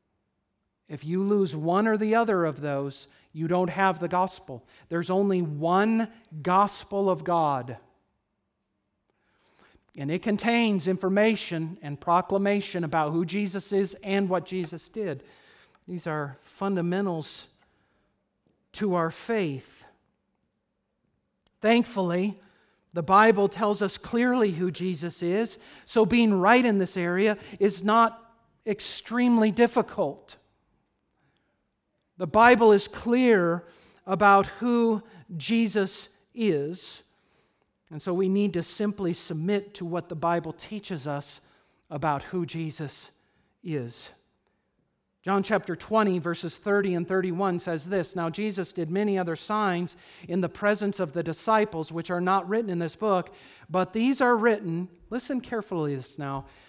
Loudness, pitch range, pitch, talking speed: -26 LUFS, 170-210 Hz, 185 Hz, 125 wpm